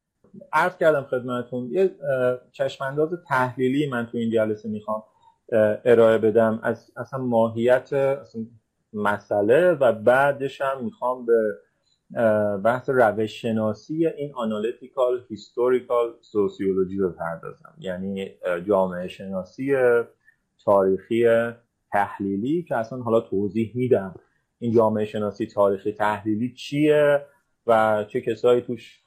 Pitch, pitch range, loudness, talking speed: 115 Hz, 105-130 Hz, -23 LUFS, 105 wpm